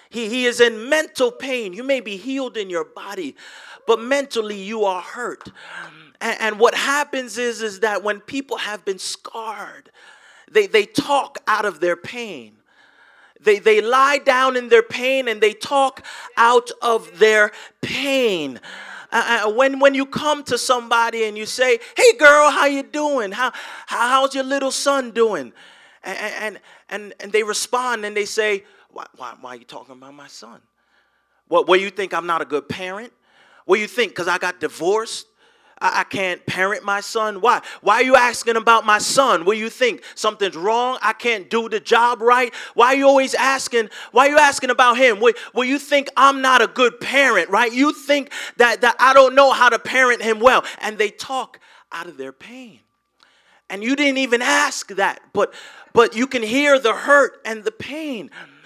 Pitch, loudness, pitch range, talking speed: 240 Hz, -17 LUFS, 215-275 Hz, 195 wpm